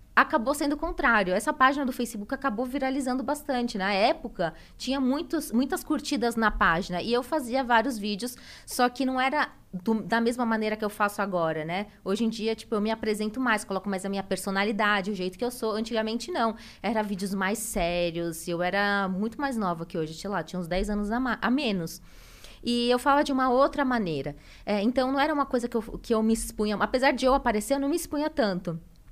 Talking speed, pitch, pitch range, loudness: 220 wpm, 225 Hz, 200-260 Hz, -27 LUFS